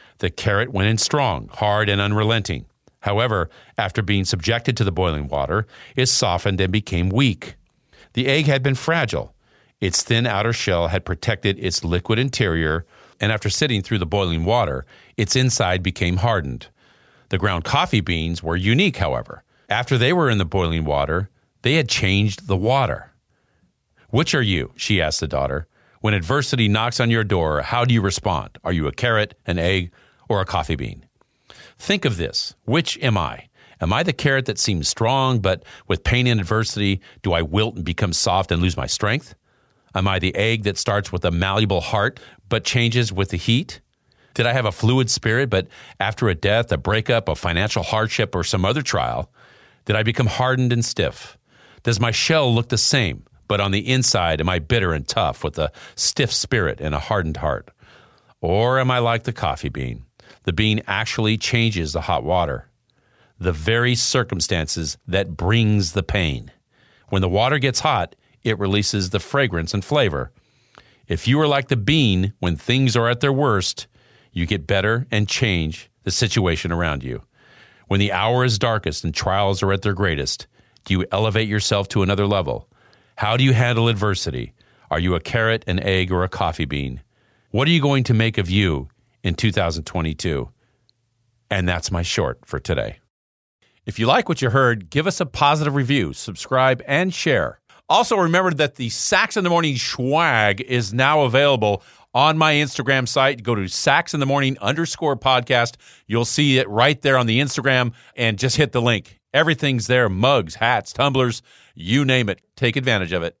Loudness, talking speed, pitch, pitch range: -20 LUFS, 185 wpm, 110 Hz, 95-125 Hz